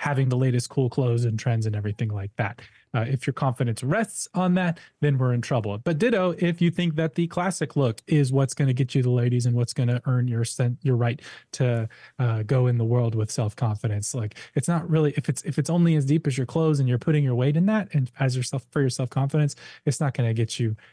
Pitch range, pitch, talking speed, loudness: 120-150 Hz, 135 Hz, 260 wpm, -24 LUFS